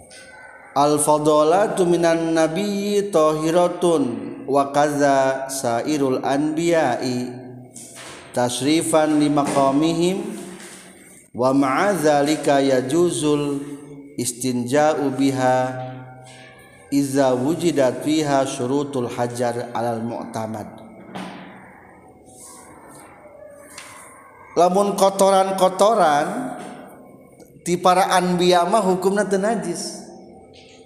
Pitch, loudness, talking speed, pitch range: 150 Hz, -19 LUFS, 60 wpm, 130-175 Hz